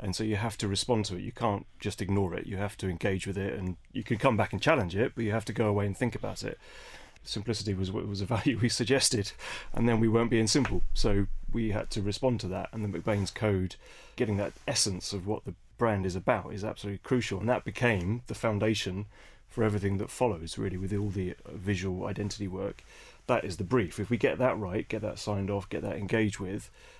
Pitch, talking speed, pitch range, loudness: 105 Hz, 235 wpm, 100-115 Hz, -31 LUFS